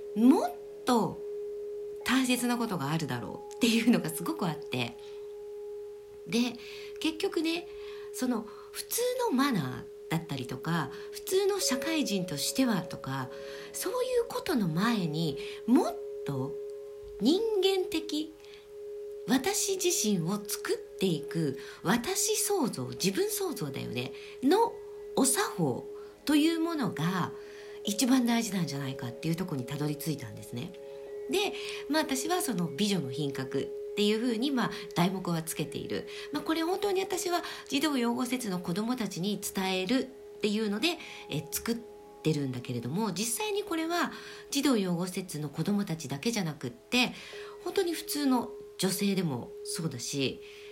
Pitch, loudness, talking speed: 235 Hz, -31 LUFS, 290 characters per minute